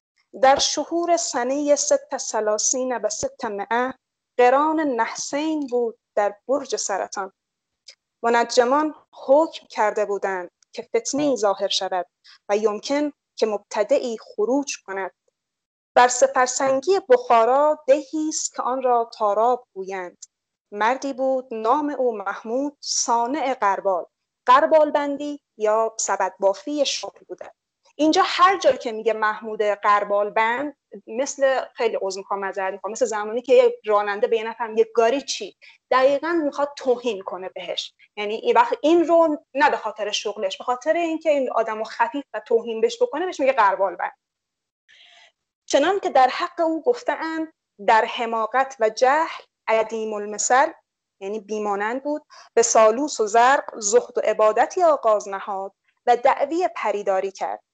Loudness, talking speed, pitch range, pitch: -21 LUFS, 140 wpm, 215-295 Hz, 250 Hz